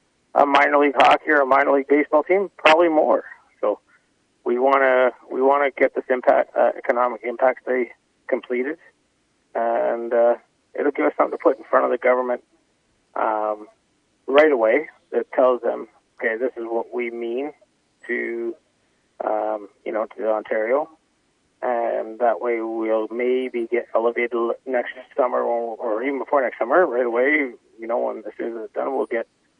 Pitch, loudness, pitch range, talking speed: 120 Hz, -21 LUFS, 115-135 Hz, 160 wpm